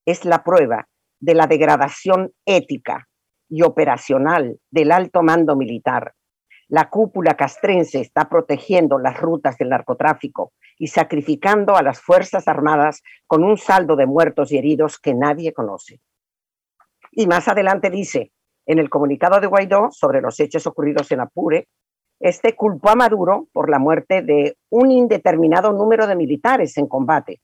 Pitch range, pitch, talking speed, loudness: 150-190 Hz, 165 Hz, 150 wpm, -17 LUFS